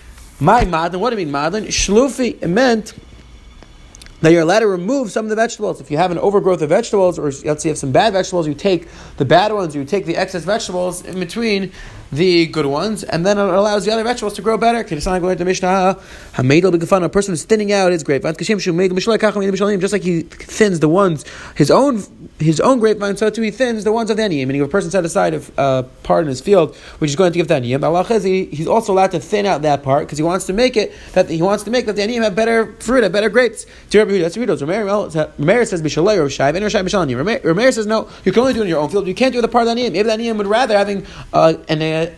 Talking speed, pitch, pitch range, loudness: 235 wpm, 190 Hz, 165-215 Hz, -16 LUFS